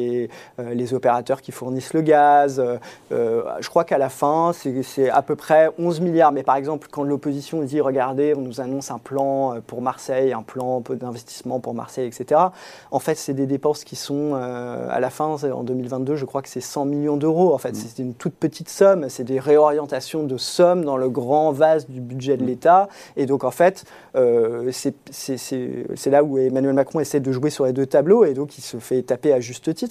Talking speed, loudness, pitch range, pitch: 205 wpm, -21 LUFS, 130-150 Hz, 140 Hz